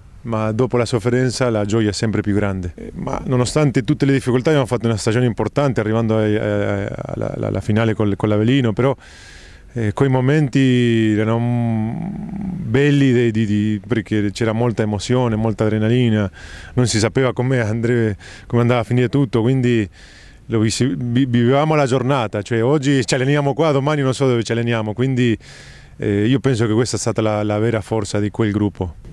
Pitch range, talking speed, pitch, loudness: 105-130 Hz, 165 wpm, 115 Hz, -18 LUFS